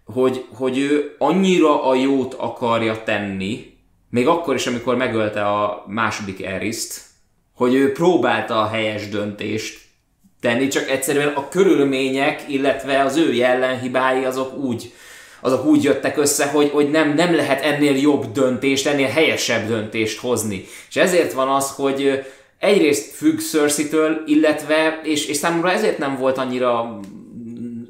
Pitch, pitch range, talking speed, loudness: 130 Hz, 115-145 Hz, 140 wpm, -19 LUFS